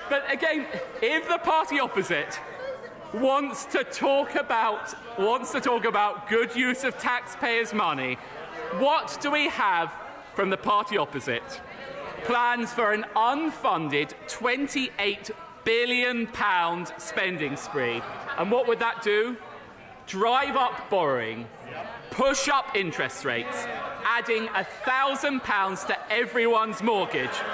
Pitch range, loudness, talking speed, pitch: 210-275 Hz, -26 LUFS, 115 wpm, 240 Hz